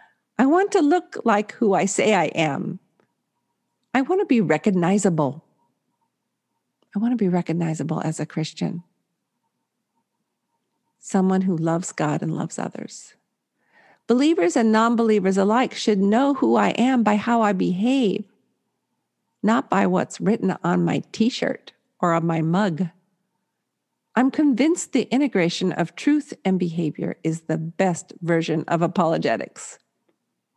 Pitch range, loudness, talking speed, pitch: 170-235 Hz, -21 LUFS, 135 wpm, 195 Hz